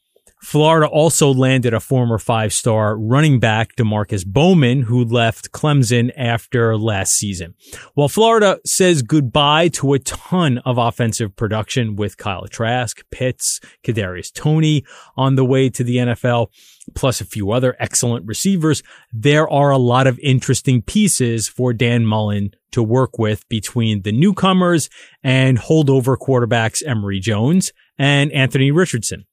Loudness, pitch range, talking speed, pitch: -16 LUFS, 110-140 Hz, 140 wpm, 125 Hz